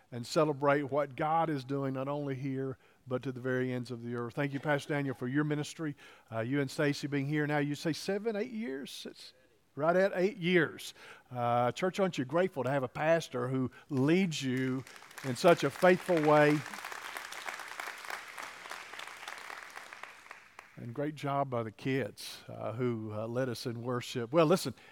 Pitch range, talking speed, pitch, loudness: 130-155 Hz, 175 wpm, 140 Hz, -33 LUFS